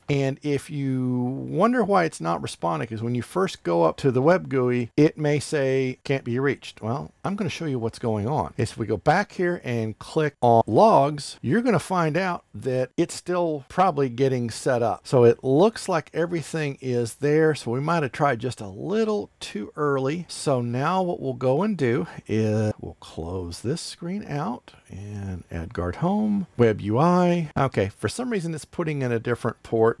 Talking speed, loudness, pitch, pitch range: 200 wpm, -24 LUFS, 135 Hz, 115-165 Hz